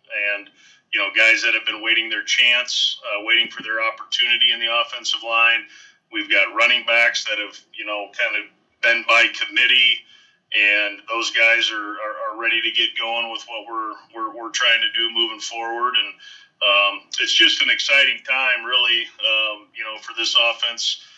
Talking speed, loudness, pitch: 185 wpm, -17 LUFS, 115 Hz